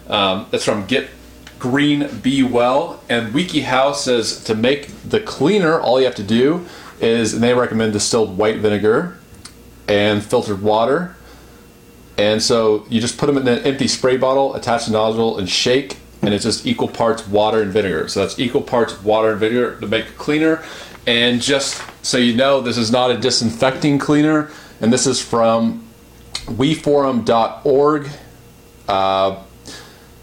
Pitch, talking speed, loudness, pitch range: 120 Hz, 165 wpm, -17 LUFS, 110-140 Hz